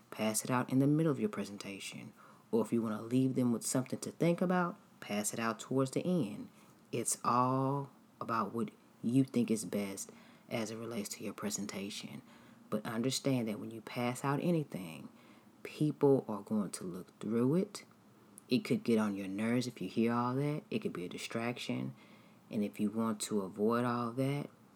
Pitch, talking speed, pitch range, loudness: 120 Hz, 195 wpm, 110-135 Hz, -35 LUFS